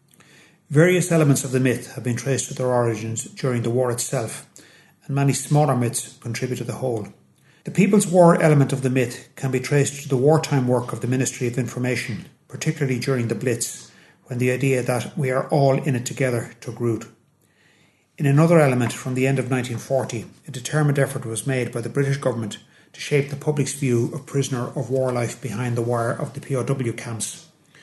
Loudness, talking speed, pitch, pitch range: -22 LUFS, 200 wpm, 130 Hz, 120-145 Hz